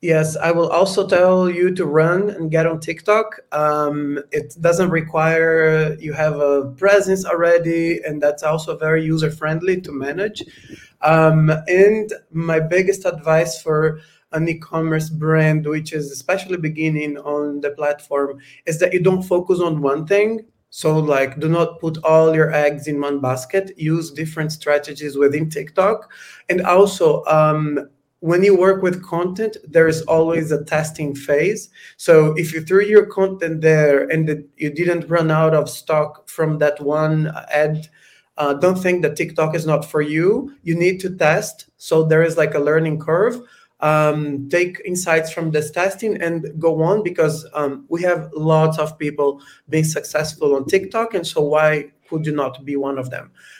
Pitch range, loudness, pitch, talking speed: 150-175 Hz, -18 LUFS, 160 Hz, 170 wpm